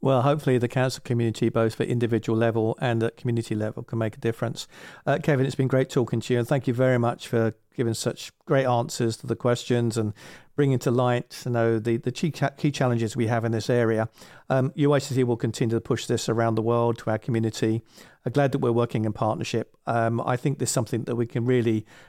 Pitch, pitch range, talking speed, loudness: 120 Hz, 115-130 Hz, 225 wpm, -25 LUFS